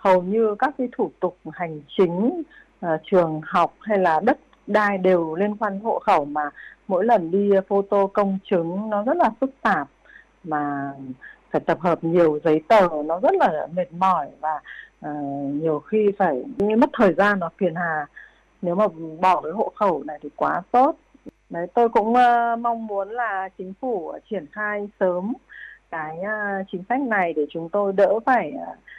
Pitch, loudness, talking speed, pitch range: 190 Hz, -22 LUFS, 185 wpm, 165-215 Hz